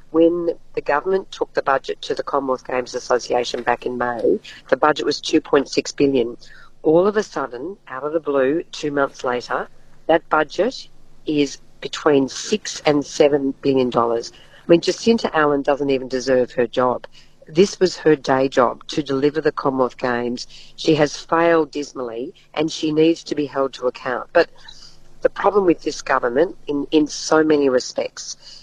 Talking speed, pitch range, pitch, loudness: 170 wpm, 130-165 Hz, 145 Hz, -20 LUFS